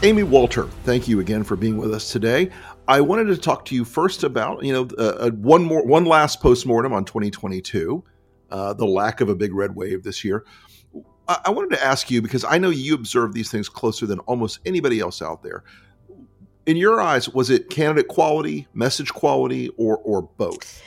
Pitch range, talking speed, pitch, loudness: 105-150 Hz, 200 wpm, 120 Hz, -20 LUFS